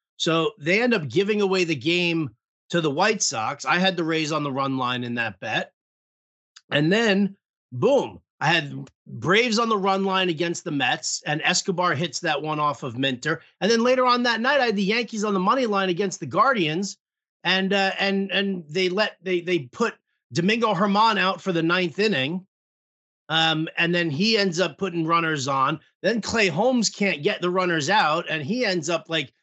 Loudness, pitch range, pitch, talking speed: -22 LUFS, 160-200 Hz, 185 Hz, 200 wpm